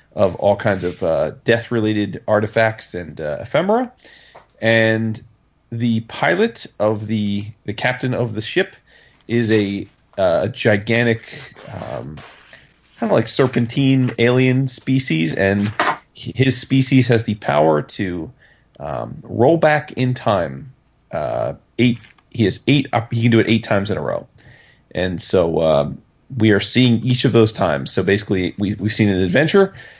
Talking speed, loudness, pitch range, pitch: 150 wpm, -18 LUFS, 105-125 Hz, 115 Hz